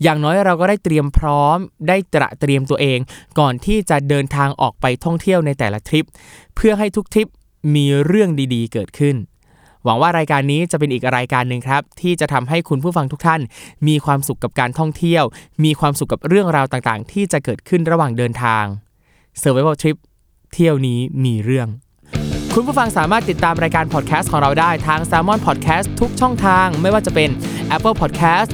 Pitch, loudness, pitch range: 150 Hz, -16 LUFS, 130-170 Hz